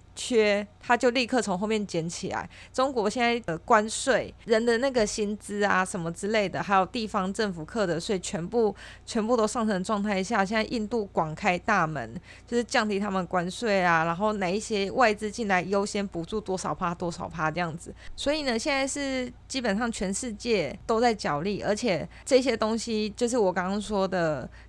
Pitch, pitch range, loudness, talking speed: 210 Hz, 185-230 Hz, -27 LUFS, 285 characters per minute